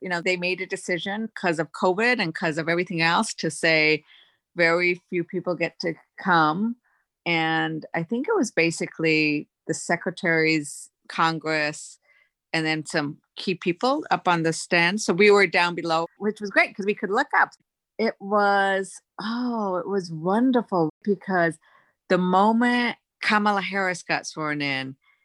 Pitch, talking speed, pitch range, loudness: 180 Hz, 160 wpm, 165-200 Hz, -23 LUFS